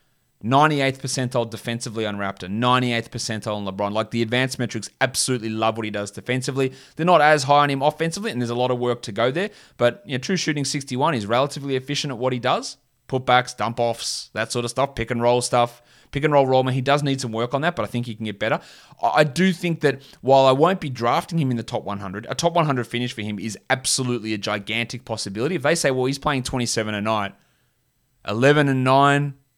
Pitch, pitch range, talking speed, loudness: 125 Hz, 115-140 Hz, 230 wpm, -22 LUFS